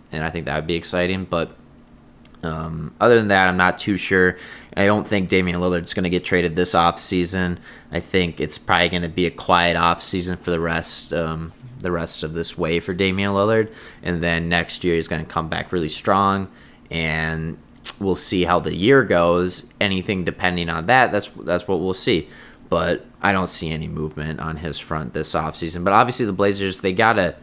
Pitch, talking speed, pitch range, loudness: 90 Hz, 205 wpm, 80-95 Hz, -20 LUFS